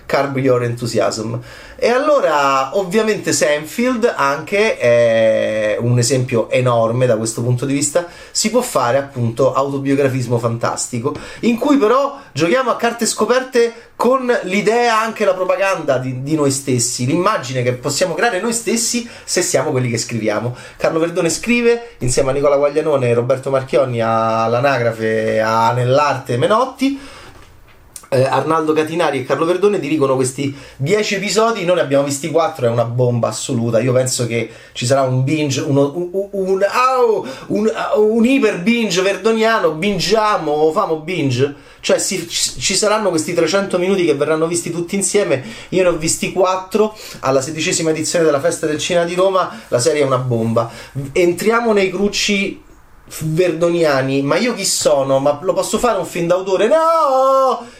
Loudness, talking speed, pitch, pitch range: -16 LUFS, 155 wpm, 160 Hz, 130-200 Hz